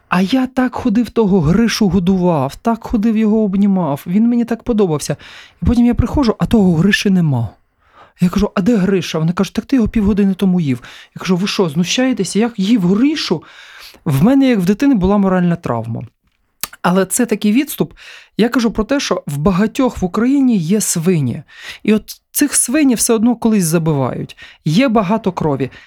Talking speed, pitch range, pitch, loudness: 180 wpm, 175-230 Hz, 205 Hz, -15 LUFS